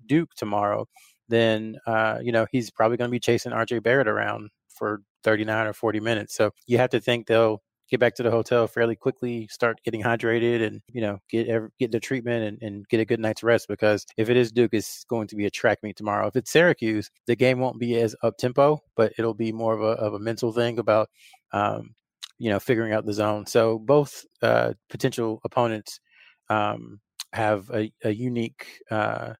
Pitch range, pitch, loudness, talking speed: 110-120 Hz, 115 Hz, -24 LUFS, 210 wpm